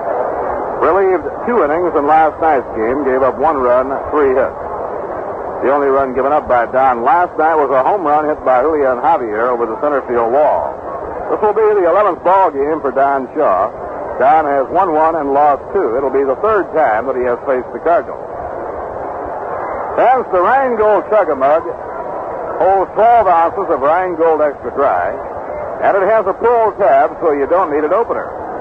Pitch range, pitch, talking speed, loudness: 140-220 Hz, 160 Hz, 180 wpm, -14 LUFS